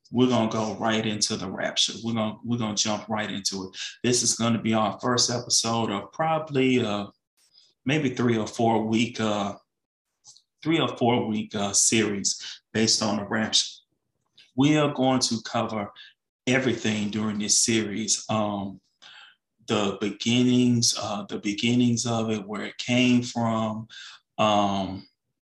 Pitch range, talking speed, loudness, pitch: 105-120 Hz, 150 wpm, -24 LUFS, 110 Hz